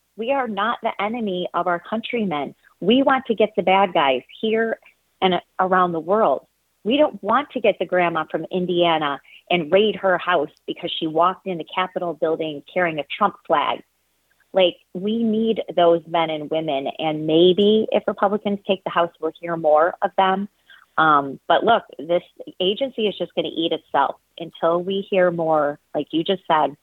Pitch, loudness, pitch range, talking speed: 185 Hz, -21 LUFS, 165-205 Hz, 185 wpm